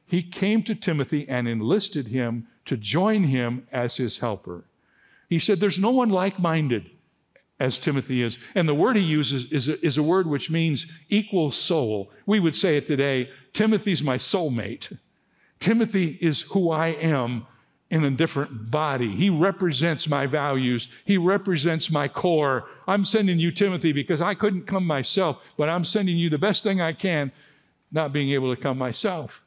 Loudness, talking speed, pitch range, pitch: -24 LUFS, 175 wpm, 135-185 Hz, 160 Hz